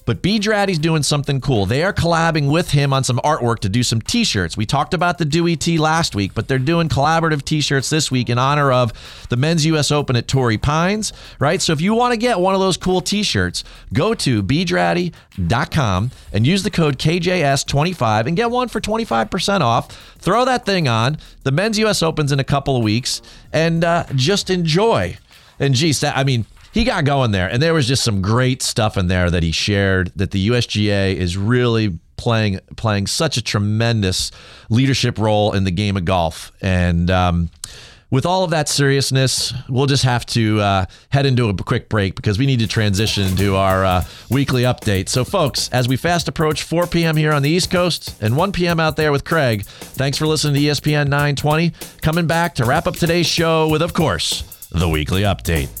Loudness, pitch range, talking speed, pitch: -17 LUFS, 110-165 Hz, 205 wpm, 135 Hz